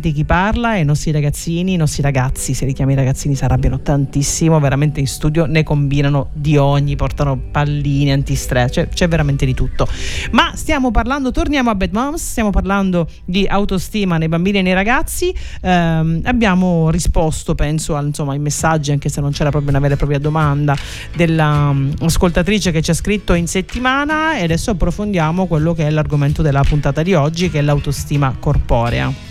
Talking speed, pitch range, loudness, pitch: 175 wpm, 140-185 Hz, -16 LUFS, 155 Hz